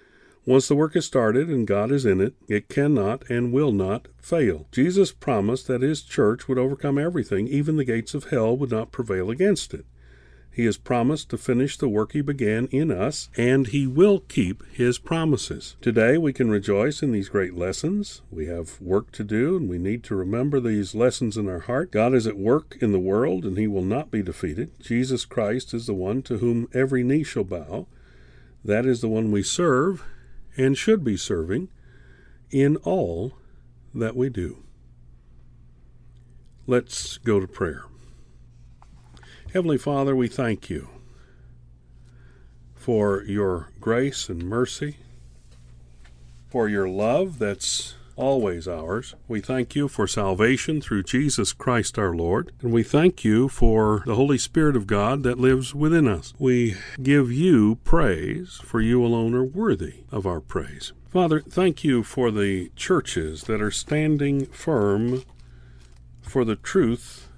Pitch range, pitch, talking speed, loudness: 95-135 Hz, 115 Hz, 160 wpm, -23 LUFS